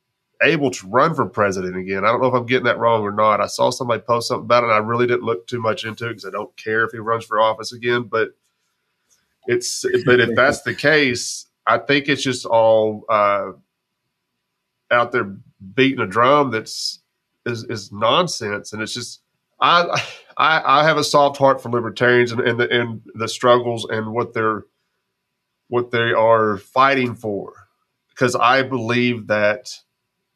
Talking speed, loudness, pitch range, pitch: 185 wpm, -18 LUFS, 110-125 Hz, 120 Hz